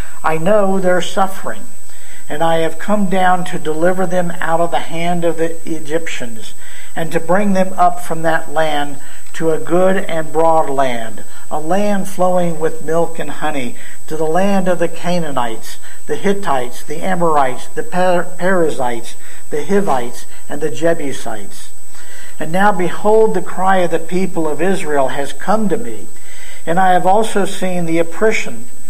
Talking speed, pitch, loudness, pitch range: 165 wpm, 170 Hz, -17 LUFS, 155-185 Hz